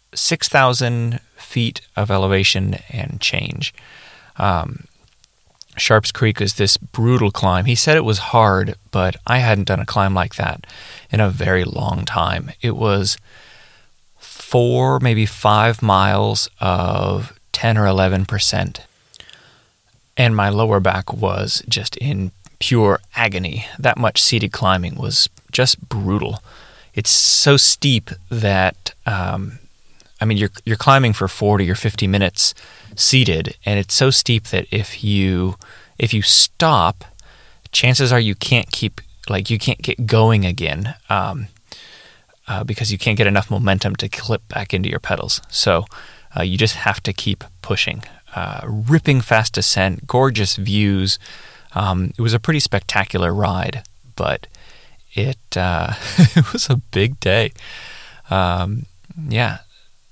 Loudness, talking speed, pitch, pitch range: -17 LUFS, 140 wpm, 105 Hz, 95-120 Hz